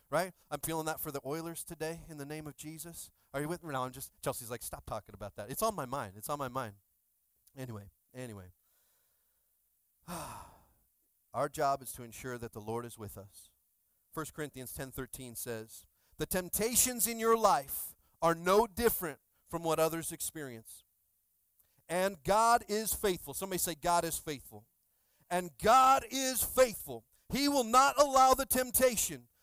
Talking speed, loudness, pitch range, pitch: 165 wpm, -32 LUFS, 120-185 Hz, 150 Hz